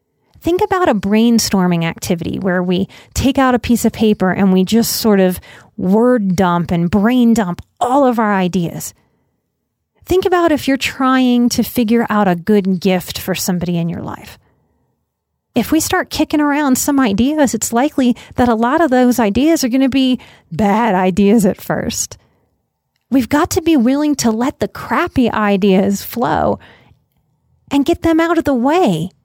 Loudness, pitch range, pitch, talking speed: -14 LUFS, 195-275 Hz, 235 Hz, 170 wpm